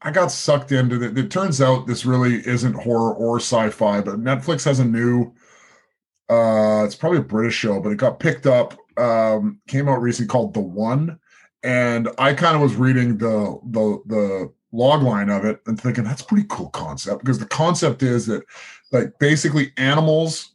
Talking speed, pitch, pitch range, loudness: 190 wpm, 125 Hz, 110-140 Hz, -19 LUFS